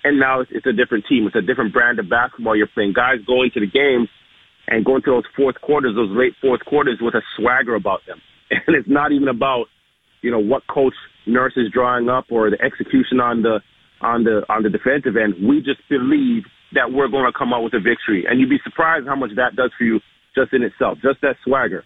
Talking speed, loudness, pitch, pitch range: 235 wpm, -18 LUFS, 130 Hz, 120-145 Hz